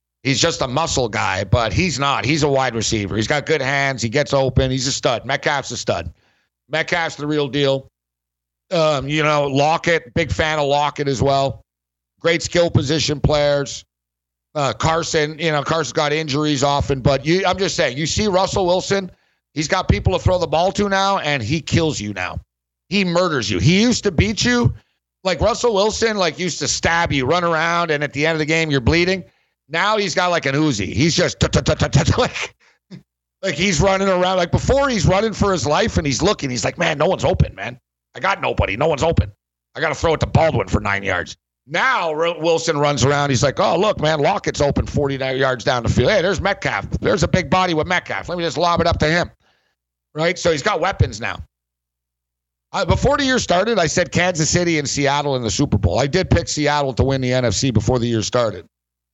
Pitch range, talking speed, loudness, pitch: 125-170 Hz, 215 wpm, -18 LUFS, 145 Hz